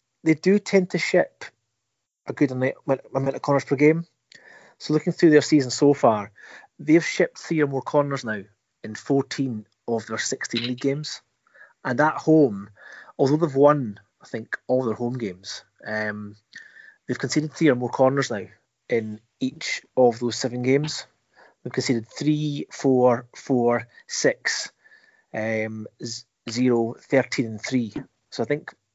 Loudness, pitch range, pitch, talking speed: -23 LUFS, 115-145 Hz, 130 Hz, 145 wpm